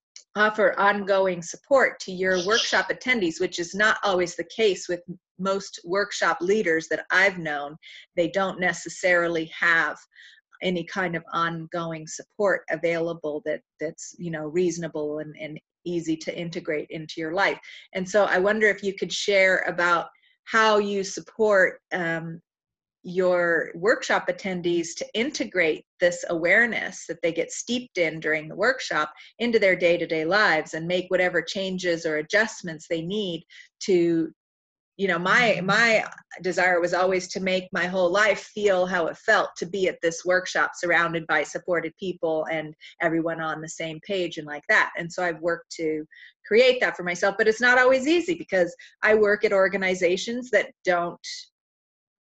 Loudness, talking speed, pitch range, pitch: -24 LUFS, 160 wpm, 165-200 Hz, 180 Hz